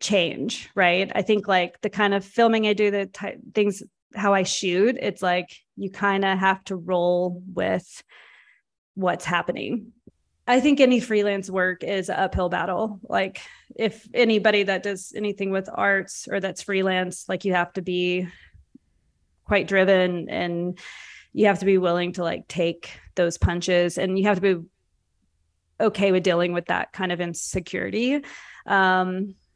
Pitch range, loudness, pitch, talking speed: 180-205 Hz, -23 LUFS, 190 Hz, 160 wpm